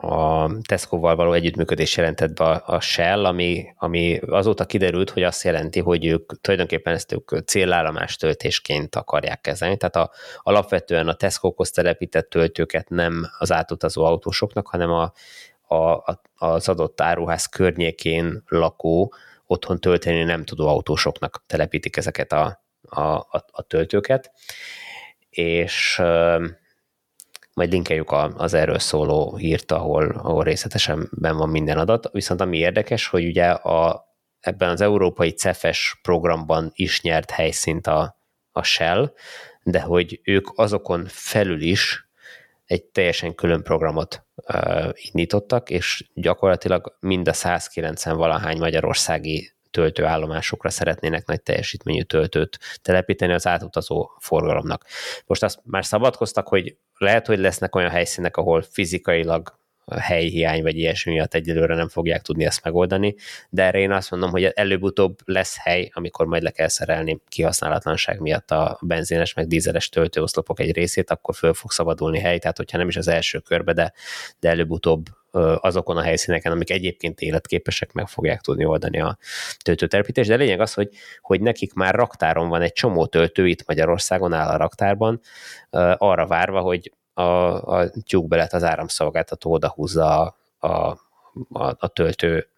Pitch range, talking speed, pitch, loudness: 80-95 Hz, 140 wpm, 85 Hz, -21 LUFS